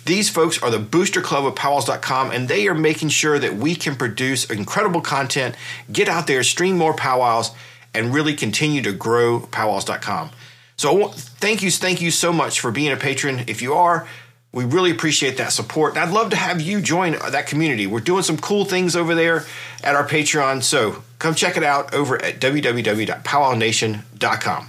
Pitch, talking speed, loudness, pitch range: 150 Hz, 185 wpm, -19 LUFS, 125-170 Hz